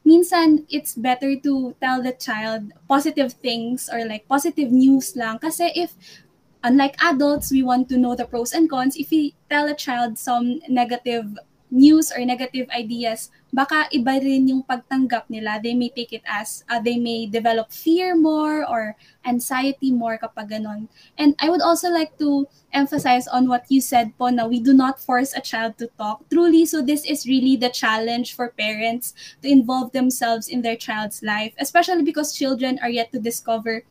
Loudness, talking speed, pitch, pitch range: -20 LUFS, 180 wpm, 255 Hz, 235-285 Hz